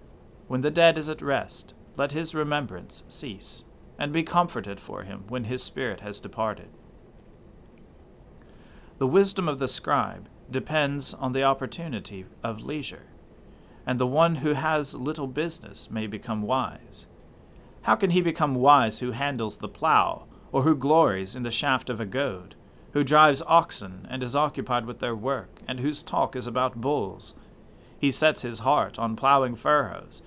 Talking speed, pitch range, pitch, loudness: 160 wpm, 115-150 Hz, 130 Hz, -26 LUFS